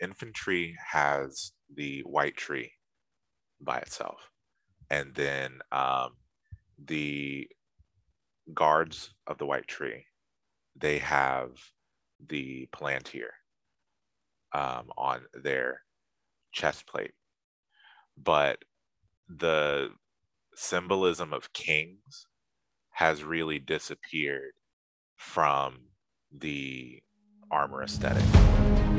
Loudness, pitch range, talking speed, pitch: -30 LUFS, 70-95 Hz, 75 wpm, 75 Hz